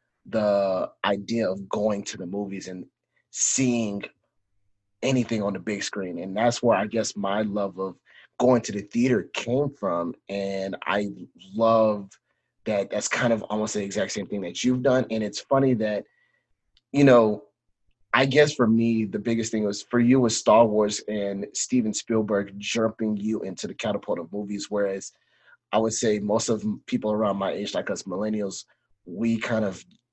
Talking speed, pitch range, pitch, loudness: 175 wpm, 100-115 Hz, 105 Hz, -25 LUFS